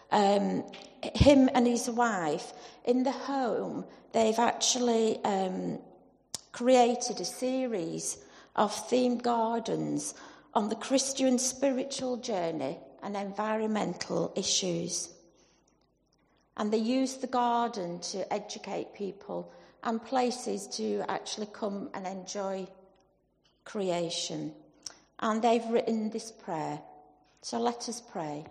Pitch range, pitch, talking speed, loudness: 190-245 Hz, 220 Hz, 105 wpm, -30 LUFS